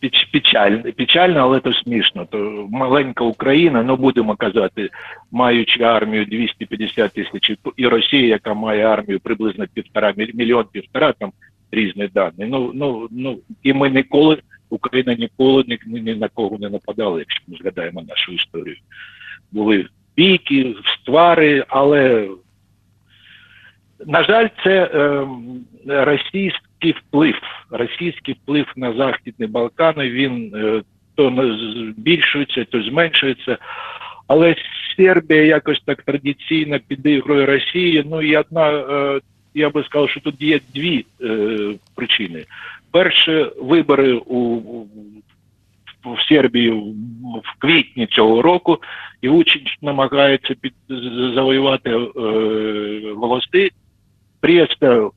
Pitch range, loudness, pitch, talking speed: 110-145 Hz, -16 LUFS, 130 Hz, 115 wpm